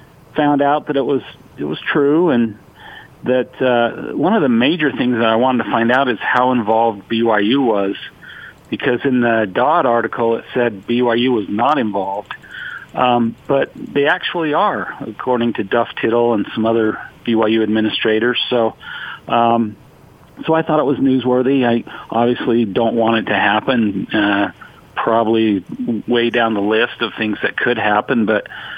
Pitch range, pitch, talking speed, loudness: 110-125 Hz, 115 Hz, 165 wpm, -16 LUFS